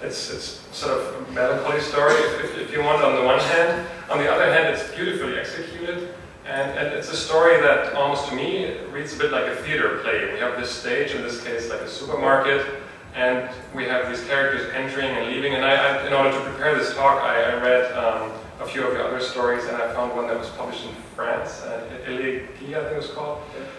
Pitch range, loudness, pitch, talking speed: 125-170 Hz, -22 LUFS, 140 Hz, 225 wpm